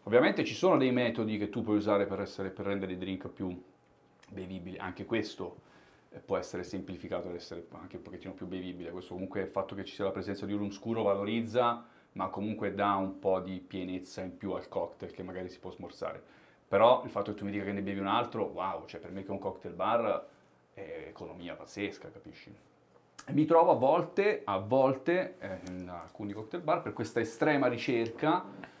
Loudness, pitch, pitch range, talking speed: -33 LUFS, 100 Hz, 90-105 Hz, 205 wpm